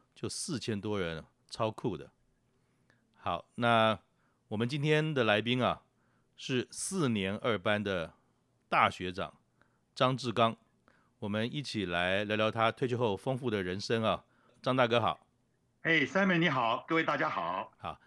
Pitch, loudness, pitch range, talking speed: 115 Hz, -32 LUFS, 105-130 Hz, 210 characters per minute